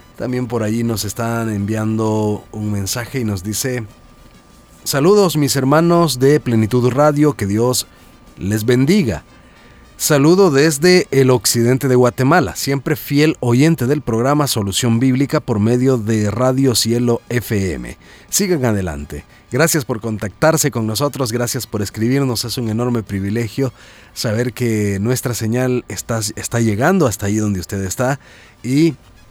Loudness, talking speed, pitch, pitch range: -16 LUFS, 135 wpm, 120 Hz, 110-135 Hz